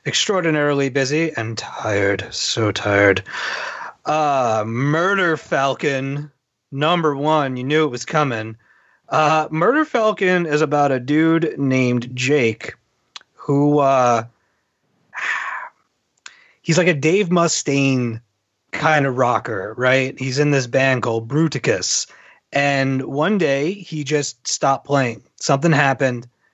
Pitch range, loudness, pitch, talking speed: 125-155 Hz, -18 LUFS, 140 Hz, 115 wpm